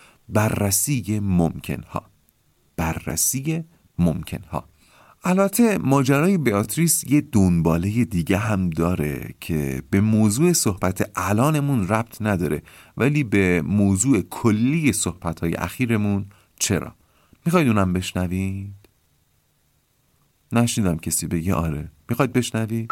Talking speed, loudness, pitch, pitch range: 95 wpm, -21 LUFS, 100 Hz, 85-120 Hz